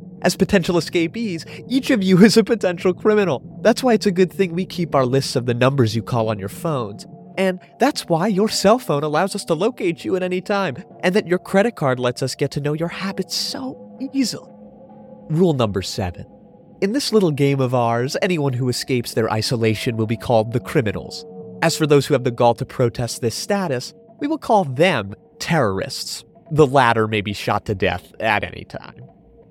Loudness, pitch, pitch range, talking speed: -19 LUFS, 170 Hz, 125-200 Hz, 205 wpm